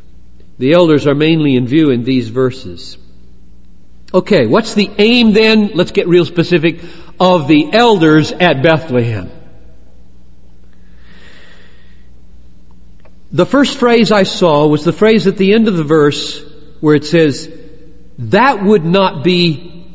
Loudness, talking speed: -11 LUFS, 130 wpm